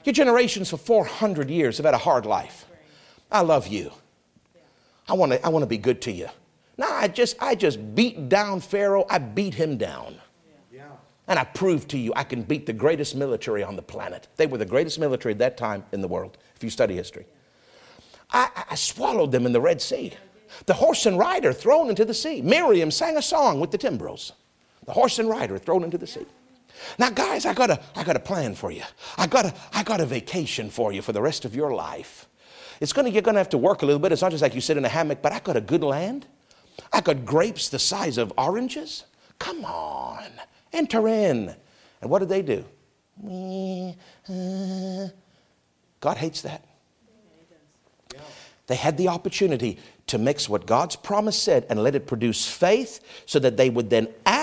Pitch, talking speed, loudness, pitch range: 190 Hz, 205 wpm, -23 LUFS, 145-225 Hz